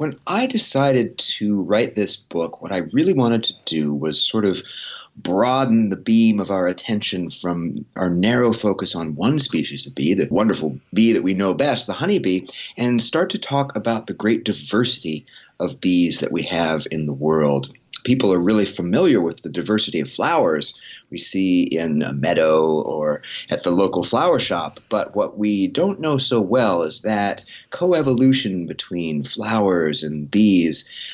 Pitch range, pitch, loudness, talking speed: 85-115 Hz, 100 Hz, -20 LUFS, 175 wpm